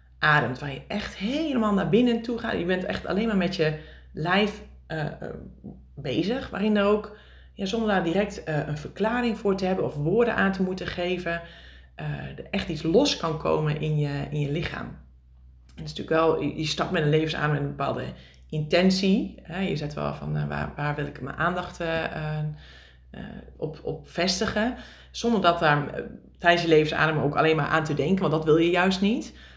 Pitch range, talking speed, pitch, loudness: 145-195 Hz, 205 wpm, 160 Hz, -25 LUFS